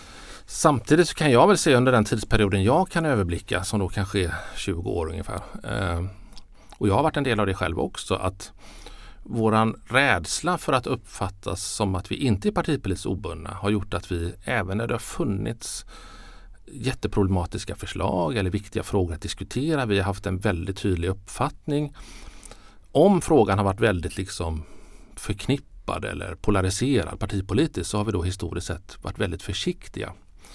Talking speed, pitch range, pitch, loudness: 165 wpm, 95-110 Hz, 100 Hz, -25 LUFS